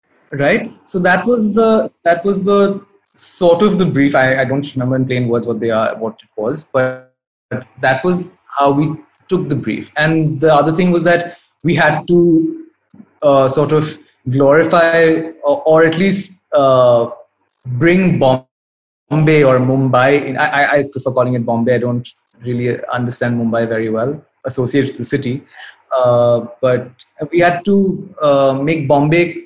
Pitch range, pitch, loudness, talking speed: 125-170 Hz, 145 Hz, -14 LUFS, 170 wpm